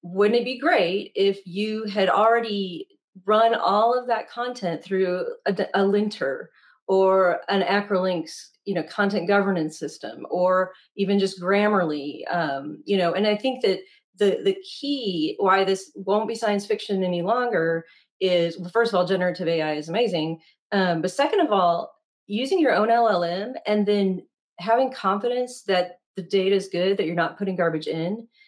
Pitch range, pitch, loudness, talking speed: 180-220 Hz, 195 Hz, -23 LUFS, 170 wpm